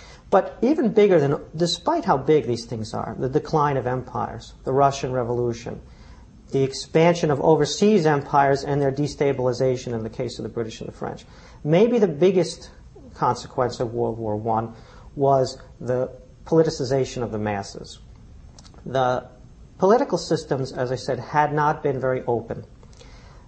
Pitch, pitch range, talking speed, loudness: 135 Hz, 120-150 Hz, 150 wpm, -22 LUFS